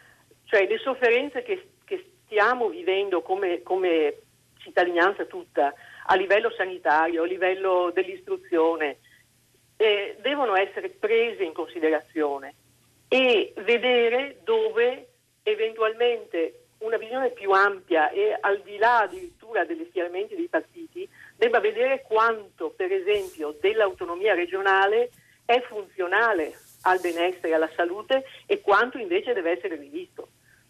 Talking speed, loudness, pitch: 115 wpm, -24 LUFS, 245 Hz